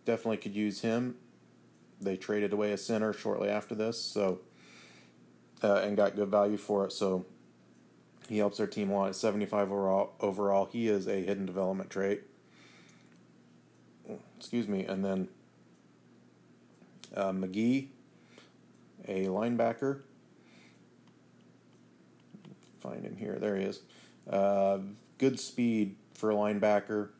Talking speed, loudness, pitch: 125 wpm, -32 LUFS, 100 Hz